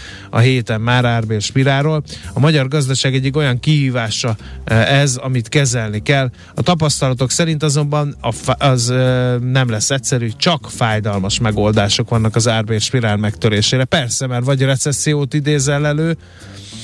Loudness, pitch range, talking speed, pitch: -15 LUFS, 110-140 Hz, 130 wpm, 125 Hz